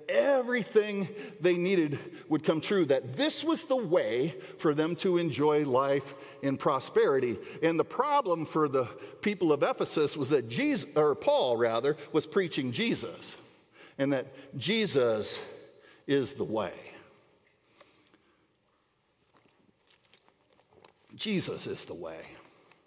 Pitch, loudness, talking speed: 180 Hz, -29 LUFS, 120 wpm